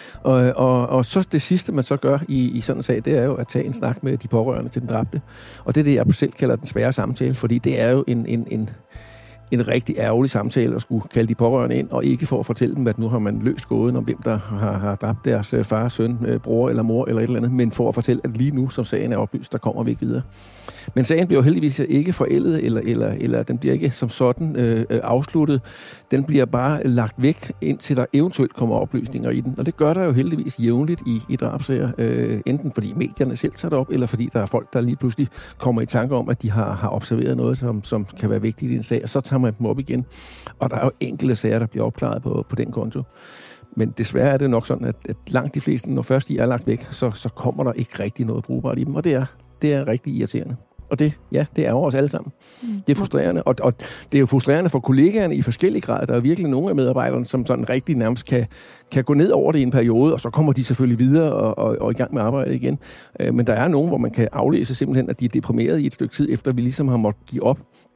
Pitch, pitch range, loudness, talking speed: 125 Hz, 115-135 Hz, -20 LUFS, 270 wpm